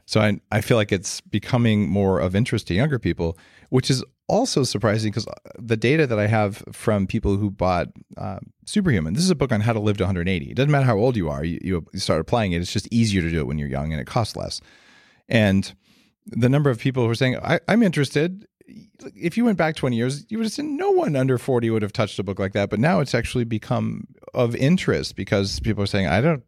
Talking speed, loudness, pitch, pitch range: 245 wpm, -22 LUFS, 115 Hz, 100-135 Hz